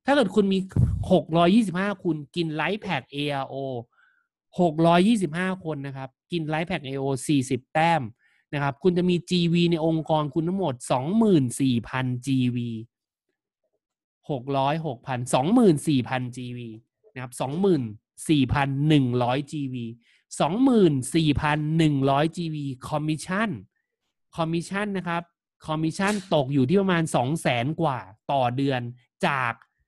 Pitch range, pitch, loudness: 130-175 Hz, 155 Hz, -24 LUFS